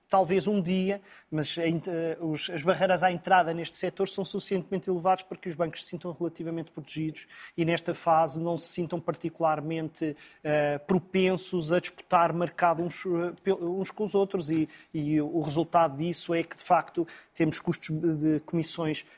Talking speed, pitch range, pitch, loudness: 150 wpm, 160-185 Hz, 170 Hz, -28 LUFS